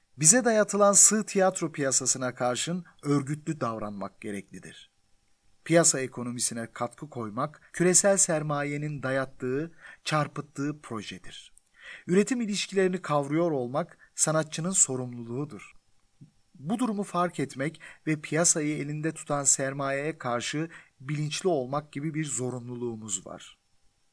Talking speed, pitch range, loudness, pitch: 100 wpm, 125-165 Hz, -26 LUFS, 145 Hz